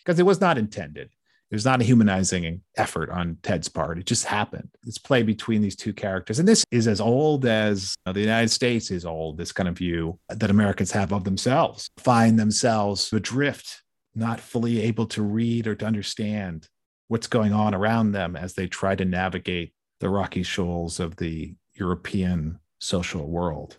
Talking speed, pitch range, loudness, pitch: 185 wpm, 90-115 Hz, -24 LUFS, 105 Hz